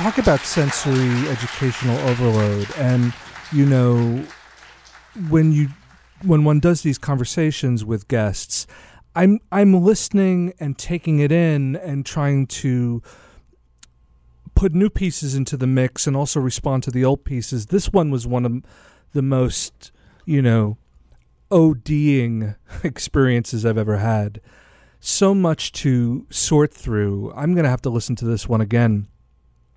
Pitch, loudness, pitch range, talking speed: 130 Hz, -19 LUFS, 115-150 Hz, 140 wpm